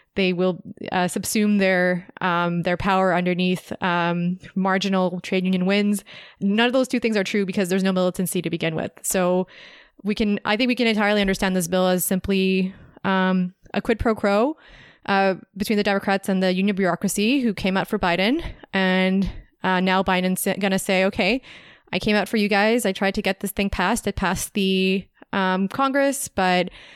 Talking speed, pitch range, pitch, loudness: 190 wpm, 185-210 Hz, 195 Hz, -22 LUFS